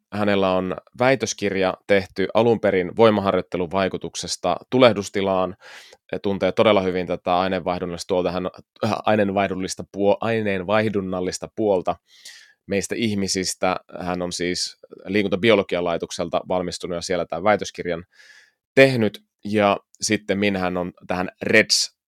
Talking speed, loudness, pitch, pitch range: 105 wpm, -22 LUFS, 95 Hz, 90-105 Hz